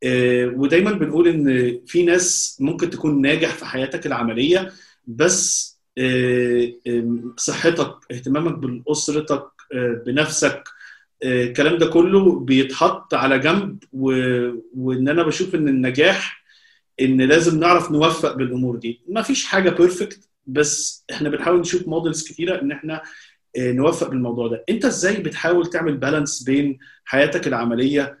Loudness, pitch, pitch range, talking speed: -19 LUFS, 150 Hz, 130-170 Hz, 120 wpm